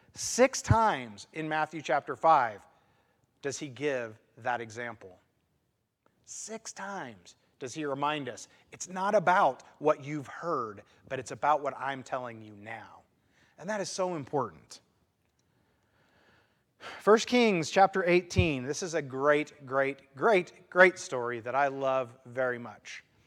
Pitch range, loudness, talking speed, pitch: 125-170 Hz, -29 LUFS, 135 wpm, 140 Hz